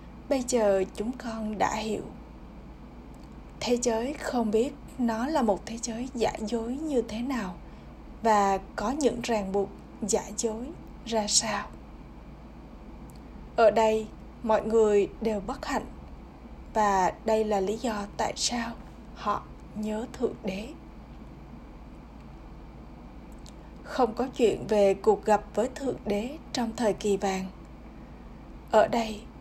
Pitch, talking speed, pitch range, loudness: 220 Hz, 125 wpm, 210-240 Hz, -28 LUFS